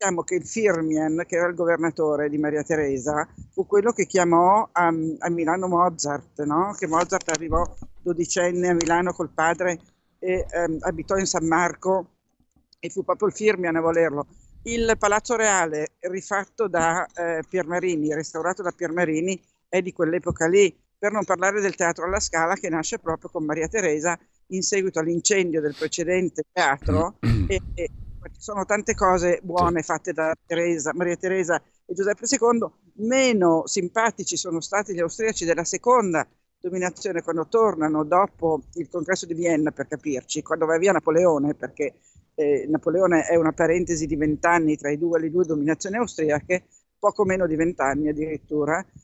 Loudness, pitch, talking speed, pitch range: -23 LUFS, 170 Hz, 160 wpm, 160-190 Hz